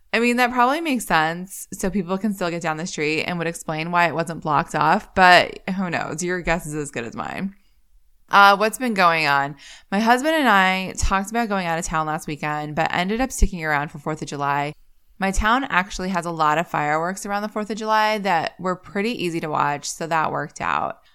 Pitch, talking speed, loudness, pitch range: 175 Hz, 230 wpm, -21 LUFS, 155-200 Hz